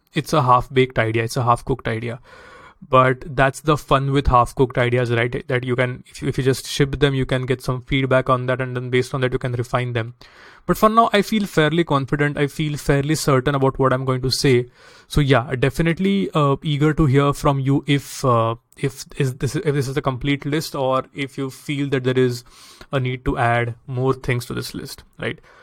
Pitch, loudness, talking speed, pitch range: 135 Hz, -20 LUFS, 225 wpm, 125-145 Hz